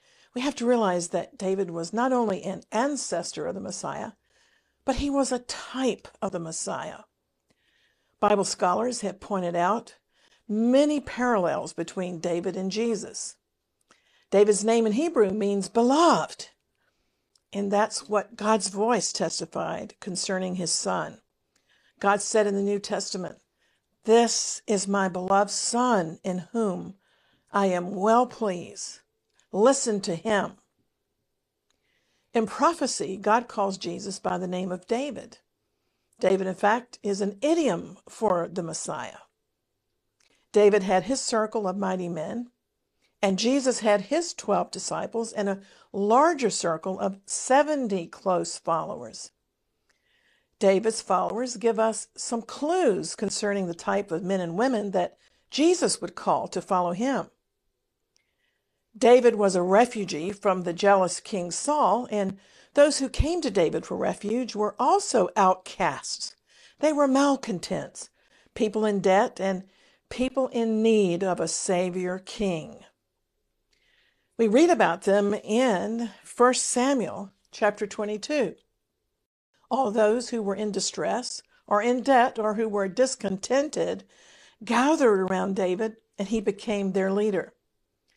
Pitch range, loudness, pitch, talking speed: 190-245 Hz, -25 LUFS, 210 Hz, 130 wpm